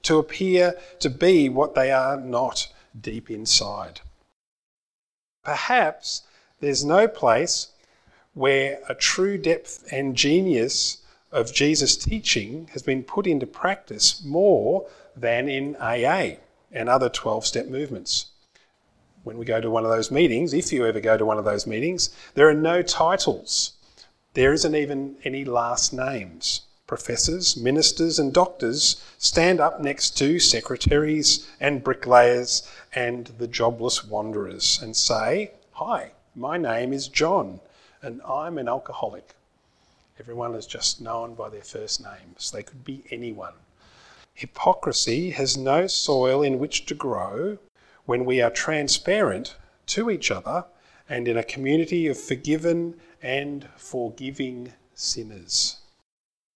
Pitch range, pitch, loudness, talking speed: 120-155 Hz, 135 Hz, -22 LUFS, 135 wpm